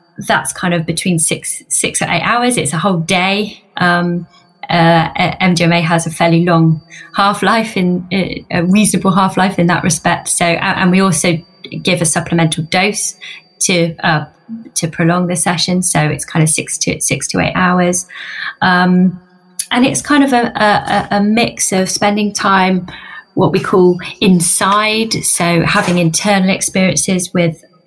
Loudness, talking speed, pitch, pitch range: -13 LUFS, 165 wpm, 180 Hz, 170-195 Hz